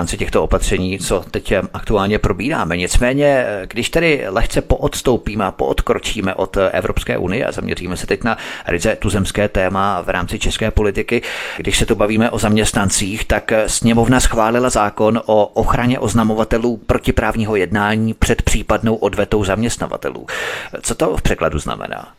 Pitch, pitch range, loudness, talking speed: 110 Hz, 100-115 Hz, -17 LUFS, 140 wpm